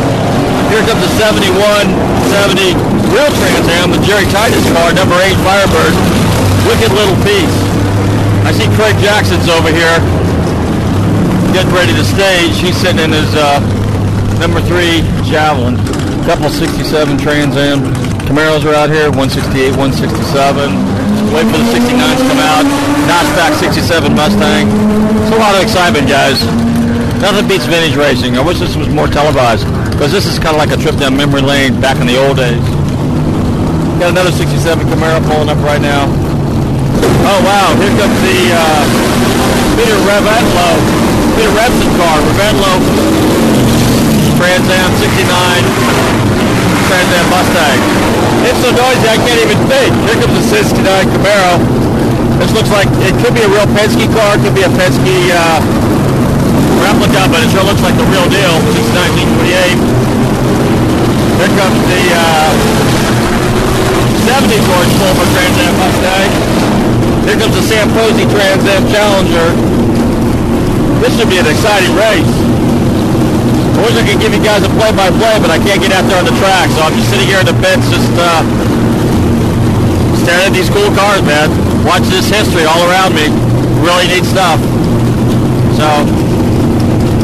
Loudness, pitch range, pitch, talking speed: -9 LUFS, 100-140 Hz, 115 Hz, 150 wpm